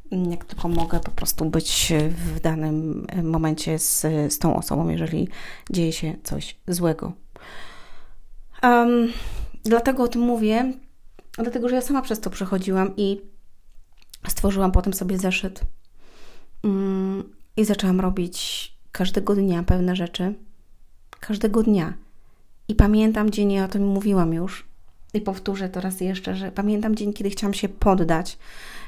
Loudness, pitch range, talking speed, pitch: -23 LUFS, 170-210 Hz, 135 wpm, 190 Hz